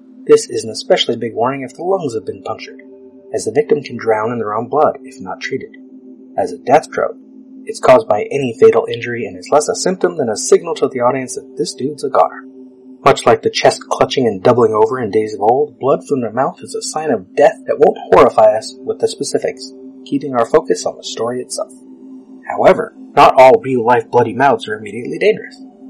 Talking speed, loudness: 220 wpm, -14 LUFS